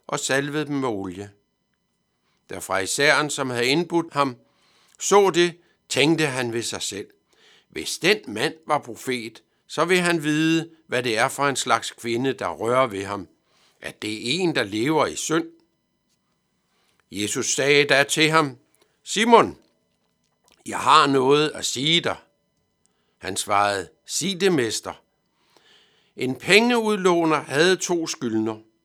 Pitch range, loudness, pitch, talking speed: 115-165 Hz, -21 LUFS, 140 Hz, 145 wpm